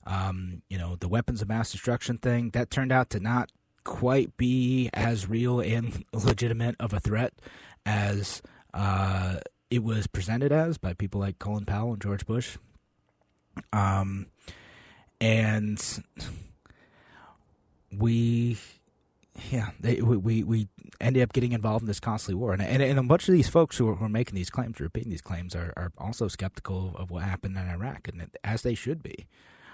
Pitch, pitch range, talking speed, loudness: 110 Hz, 95-120 Hz, 170 wpm, -28 LUFS